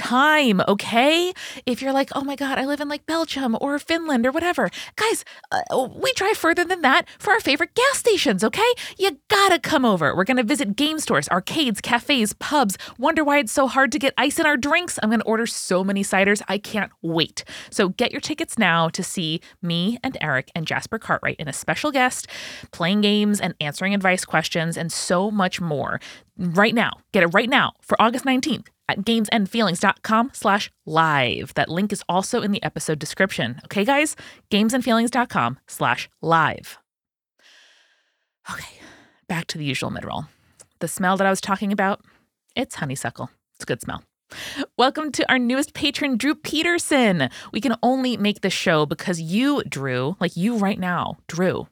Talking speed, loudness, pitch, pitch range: 180 wpm, -21 LUFS, 225 Hz, 185-280 Hz